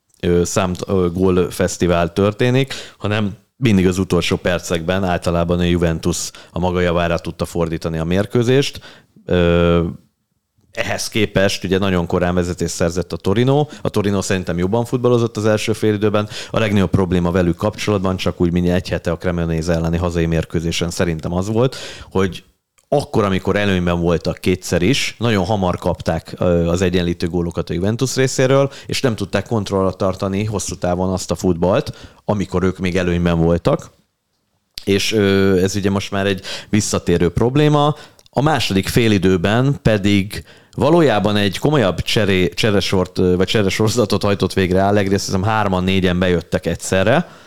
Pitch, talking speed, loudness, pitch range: 95 Hz, 145 wpm, -17 LUFS, 90-105 Hz